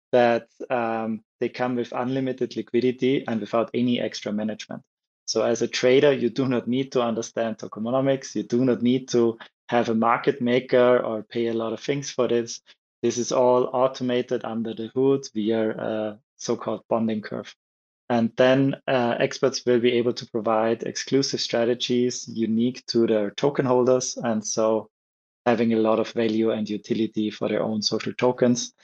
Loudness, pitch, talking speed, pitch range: -24 LUFS, 120 Hz, 175 wpm, 110-125 Hz